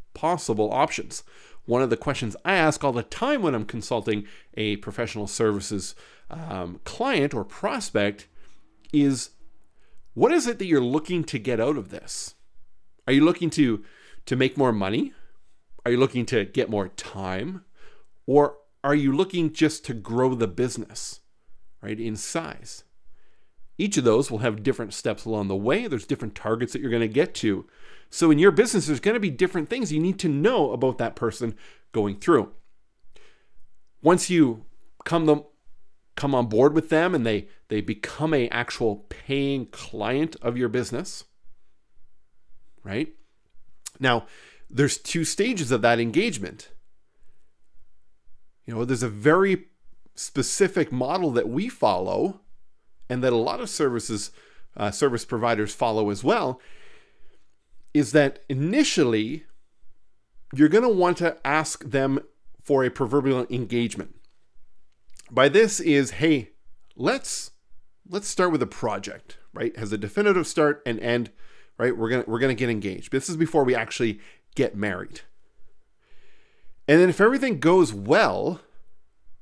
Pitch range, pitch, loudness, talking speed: 110-155 Hz, 130 Hz, -24 LUFS, 150 wpm